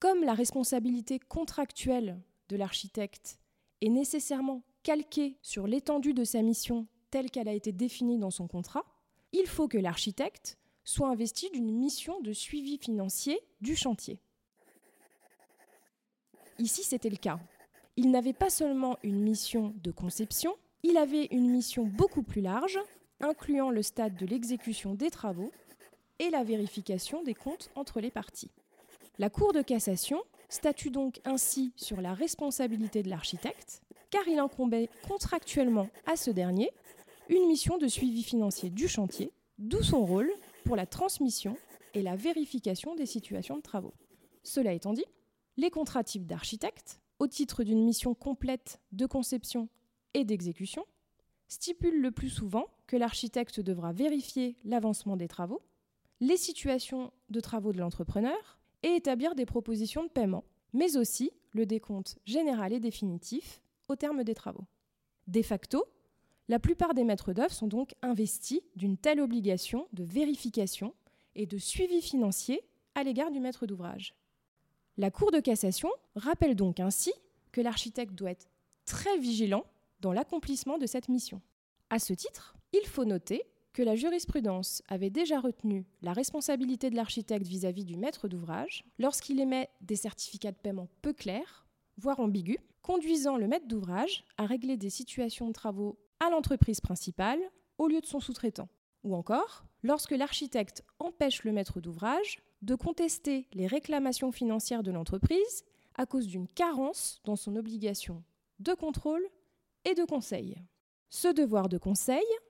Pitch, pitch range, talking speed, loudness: 245 Hz, 210-295 Hz, 150 wpm, -33 LUFS